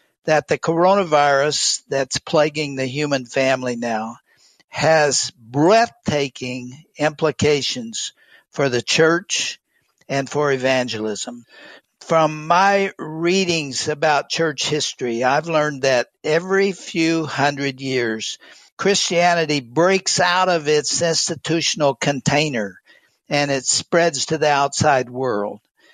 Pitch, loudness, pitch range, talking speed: 150 Hz, -19 LUFS, 135-165 Hz, 105 wpm